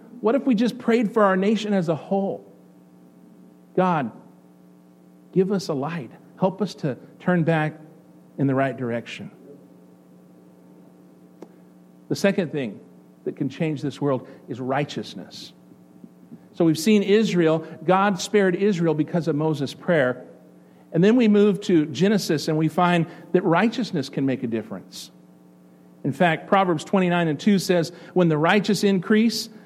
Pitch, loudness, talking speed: 160 Hz, -22 LUFS, 145 wpm